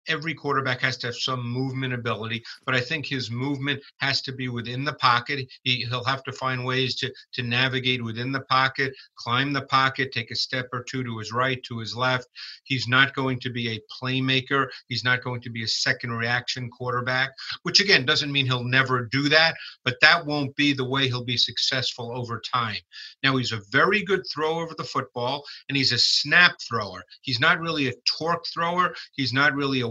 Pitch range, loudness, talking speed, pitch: 125-140 Hz, -24 LUFS, 210 wpm, 130 Hz